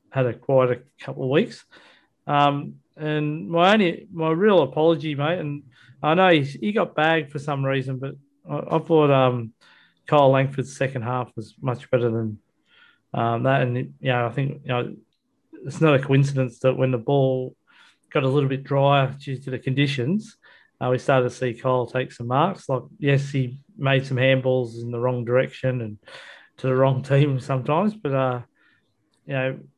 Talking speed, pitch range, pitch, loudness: 185 wpm, 130-150 Hz, 135 Hz, -22 LUFS